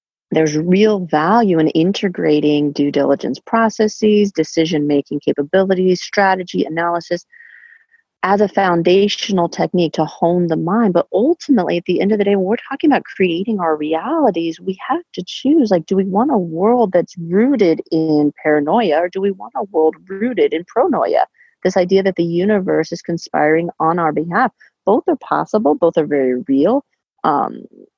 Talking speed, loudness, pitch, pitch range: 165 wpm, -16 LUFS, 185 Hz, 160-215 Hz